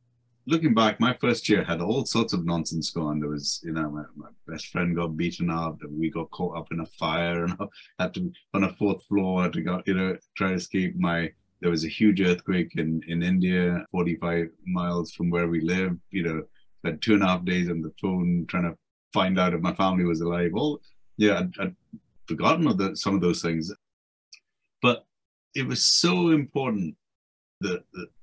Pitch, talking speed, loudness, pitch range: 90 Hz, 210 wpm, -26 LUFS, 85-95 Hz